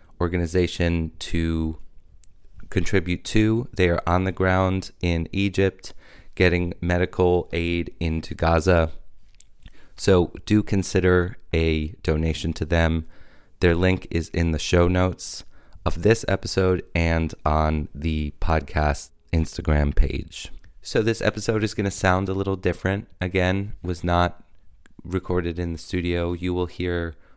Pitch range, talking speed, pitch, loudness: 80-95 Hz, 130 wpm, 90 Hz, -23 LUFS